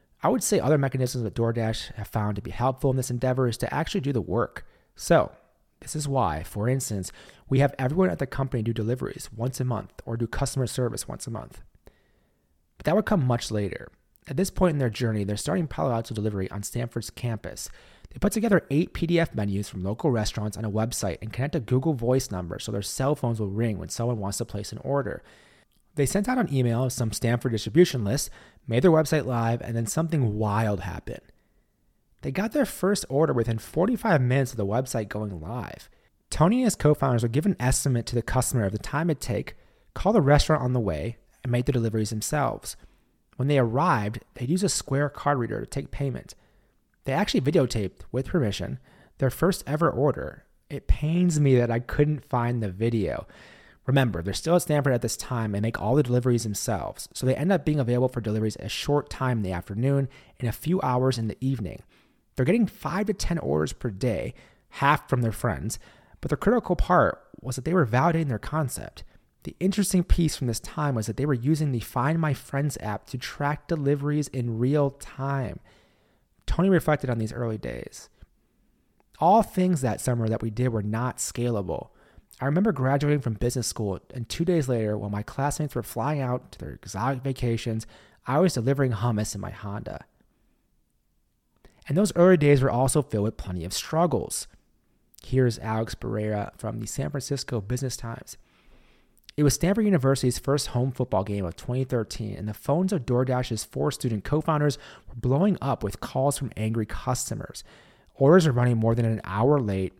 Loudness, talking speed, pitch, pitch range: -26 LUFS, 200 wpm, 125 Hz, 110-145 Hz